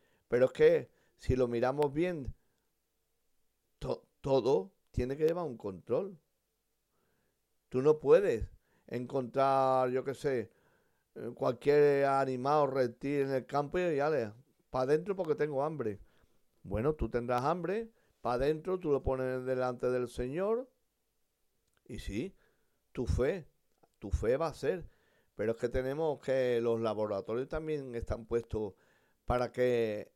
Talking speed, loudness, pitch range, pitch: 135 wpm, -33 LUFS, 125-155 Hz, 135 Hz